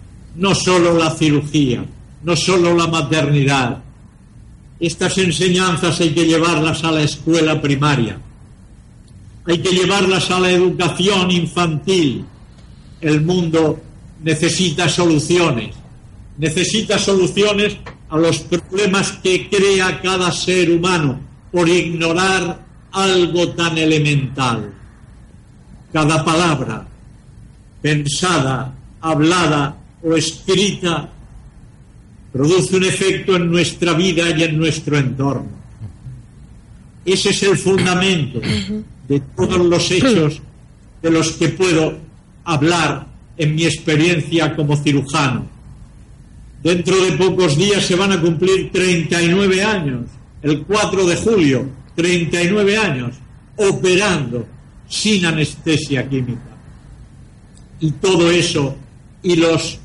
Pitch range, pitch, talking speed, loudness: 135-180 Hz, 165 Hz, 100 wpm, -16 LUFS